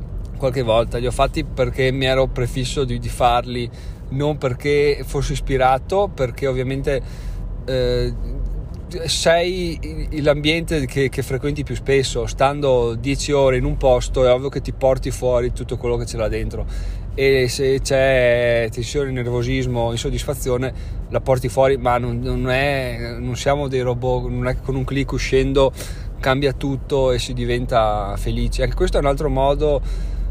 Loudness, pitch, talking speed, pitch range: -20 LUFS, 130 Hz, 160 wpm, 120-135 Hz